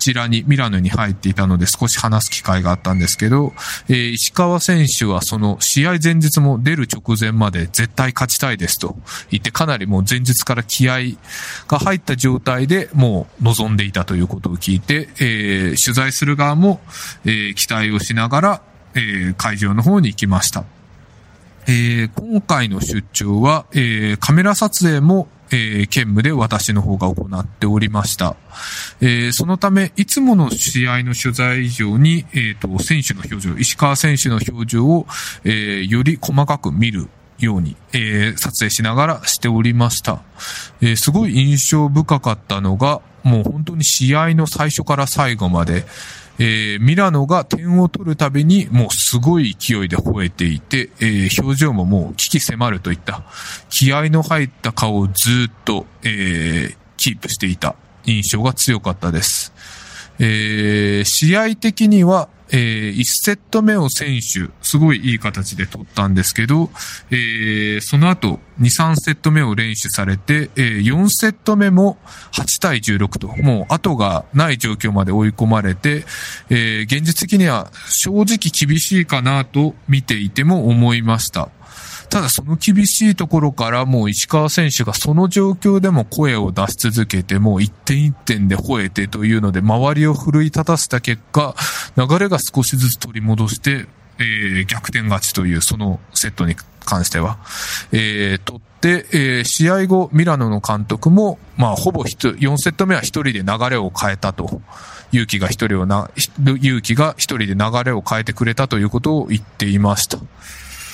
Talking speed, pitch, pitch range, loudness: 310 characters per minute, 120 Hz, 105-150 Hz, -16 LUFS